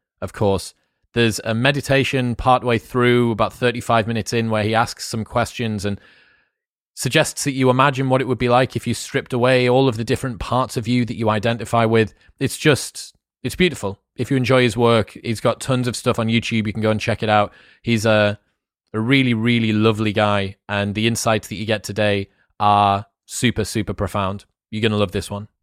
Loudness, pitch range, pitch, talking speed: -19 LUFS, 105-125 Hz, 115 Hz, 205 wpm